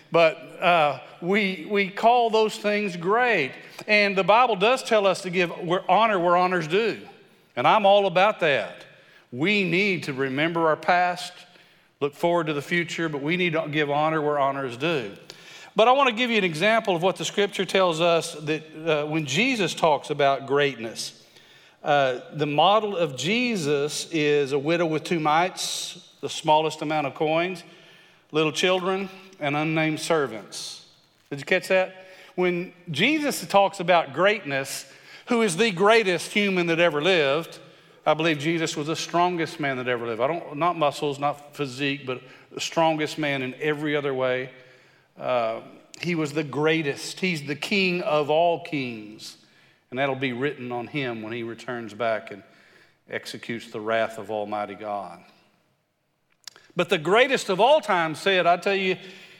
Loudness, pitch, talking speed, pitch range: -23 LUFS, 165 Hz, 170 wpm, 145-185 Hz